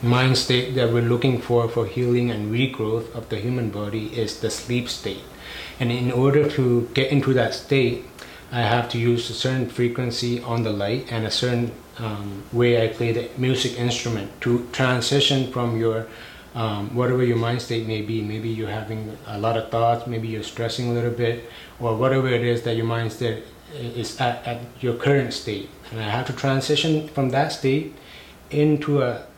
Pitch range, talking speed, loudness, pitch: 115-125 Hz, 190 wpm, -23 LUFS, 120 Hz